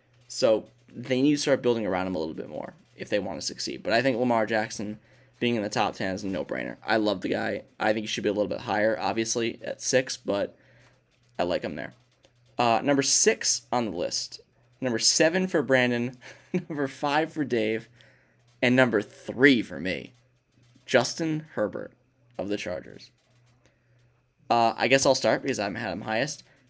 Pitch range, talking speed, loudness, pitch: 115-130 Hz, 190 wpm, -26 LUFS, 125 Hz